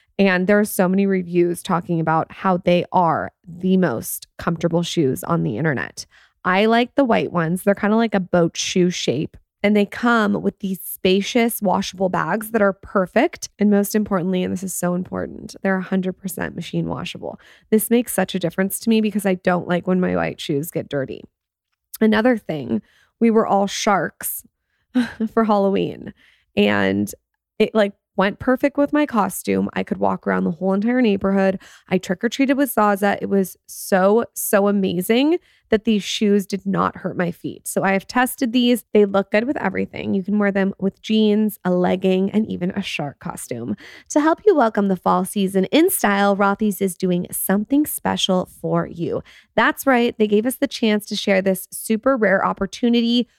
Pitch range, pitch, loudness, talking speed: 180-220 Hz, 195 Hz, -20 LUFS, 185 wpm